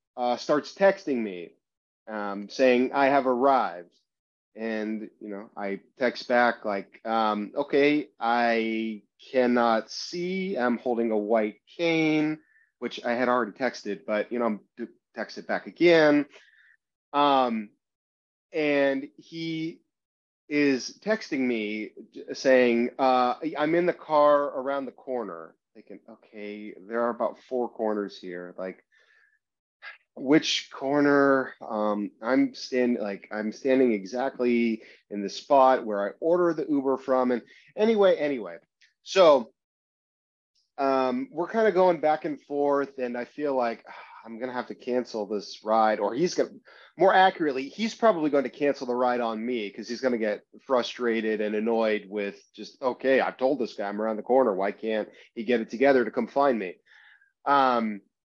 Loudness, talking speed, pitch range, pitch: -26 LUFS, 150 wpm, 110-145 Hz, 125 Hz